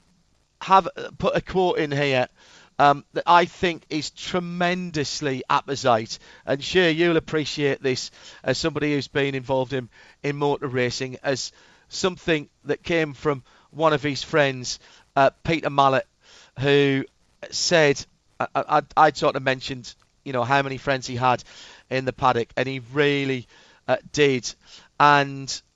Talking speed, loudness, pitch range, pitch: 140 wpm, -23 LUFS, 130-155 Hz, 140 Hz